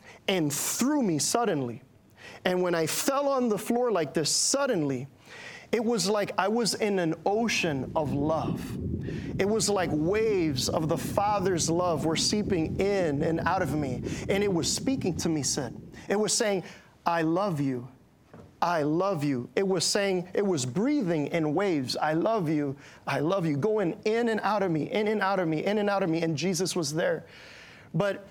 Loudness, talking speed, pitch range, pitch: -27 LUFS, 190 wpm, 155-205 Hz, 180 Hz